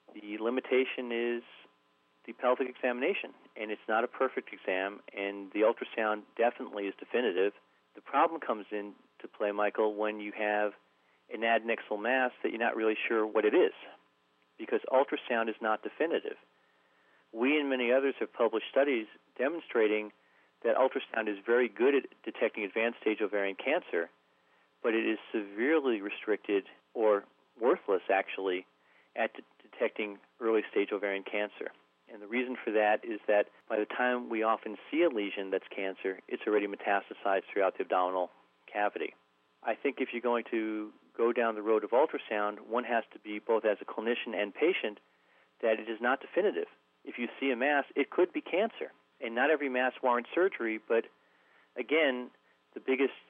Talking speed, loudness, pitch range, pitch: 165 wpm, -32 LUFS, 95-120 Hz, 105 Hz